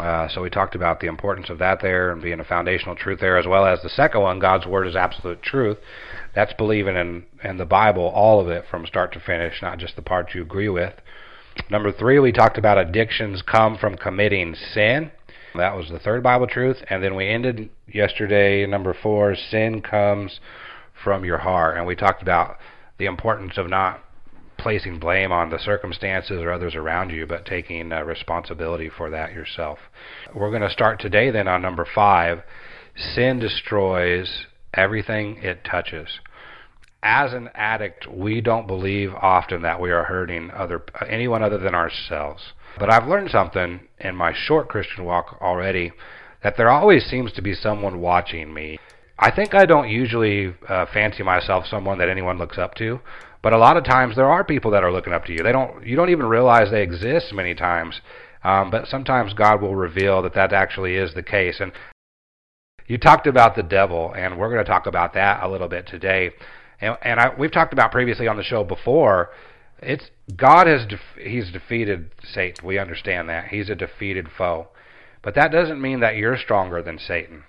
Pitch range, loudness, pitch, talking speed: 90-110 Hz, -20 LUFS, 95 Hz, 195 wpm